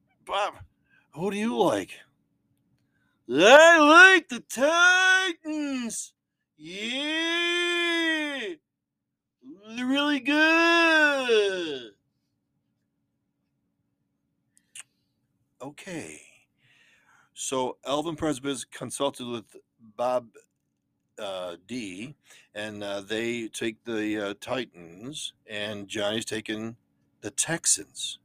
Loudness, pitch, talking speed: -23 LUFS, 150 Hz, 75 wpm